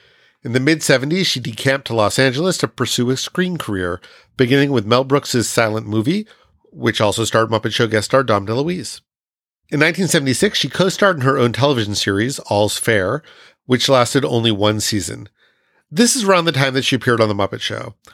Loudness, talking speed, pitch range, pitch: -17 LUFS, 190 wpm, 110-145 Hz, 125 Hz